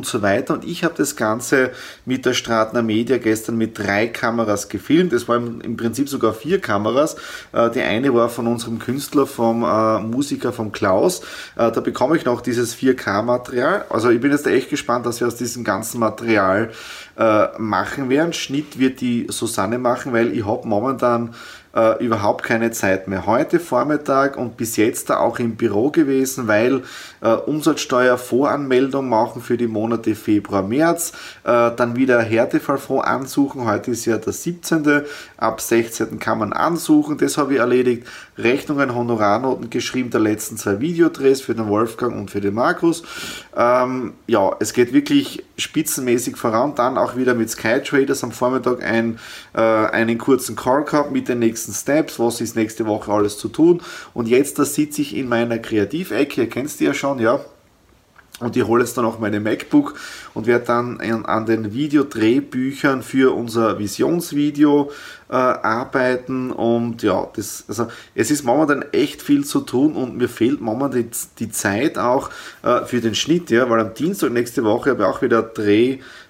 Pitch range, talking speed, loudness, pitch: 115-140 Hz, 170 wpm, -19 LUFS, 120 Hz